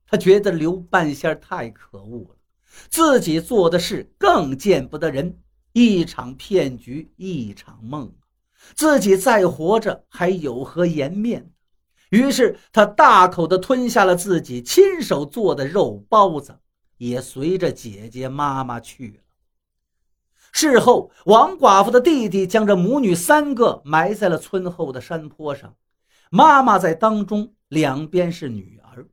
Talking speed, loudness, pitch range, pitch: 200 characters per minute, -17 LUFS, 130-200 Hz, 165 Hz